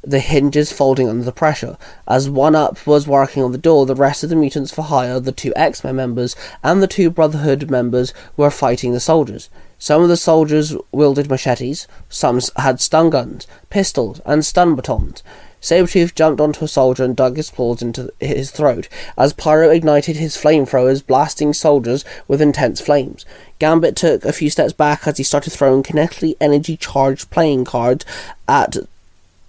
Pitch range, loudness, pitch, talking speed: 130-155 Hz, -15 LUFS, 145 Hz, 175 wpm